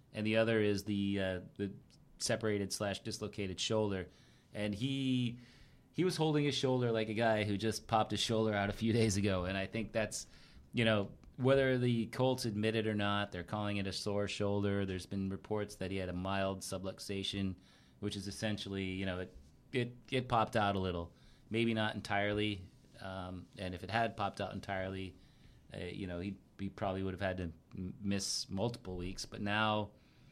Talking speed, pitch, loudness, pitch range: 195 wpm, 100 Hz, -37 LUFS, 95-110 Hz